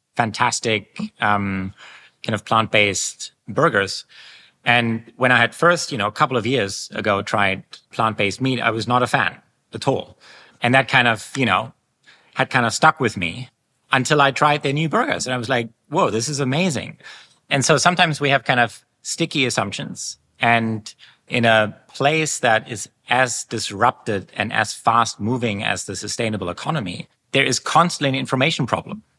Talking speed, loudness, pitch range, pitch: 175 wpm, -19 LUFS, 110-140 Hz, 120 Hz